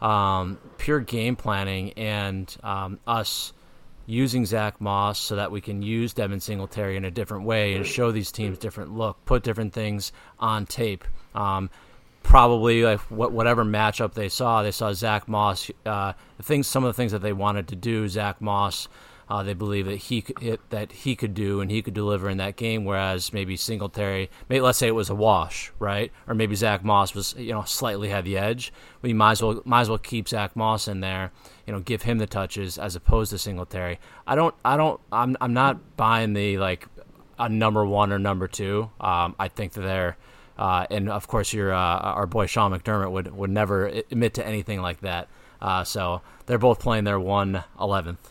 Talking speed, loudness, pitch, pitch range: 205 wpm, -25 LUFS, 105 Hz, 100-115 Hz